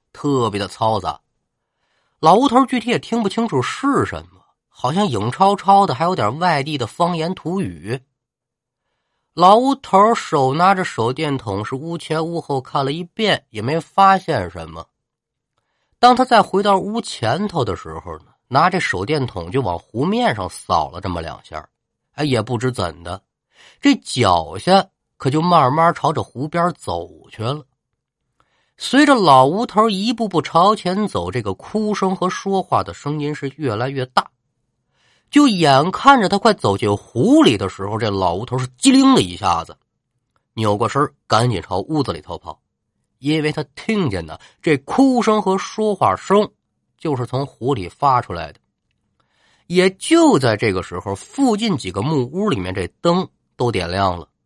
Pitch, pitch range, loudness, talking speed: 150 Hz, 120-200 Hz, -17 LUFS, 230 characters per minute